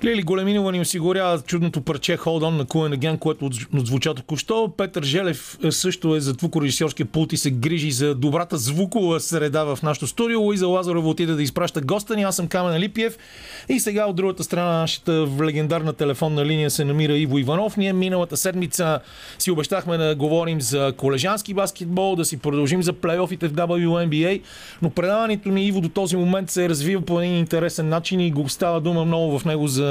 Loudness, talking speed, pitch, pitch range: -22 LUFS, 195 wpm, 170 Hz, 155-185 Hz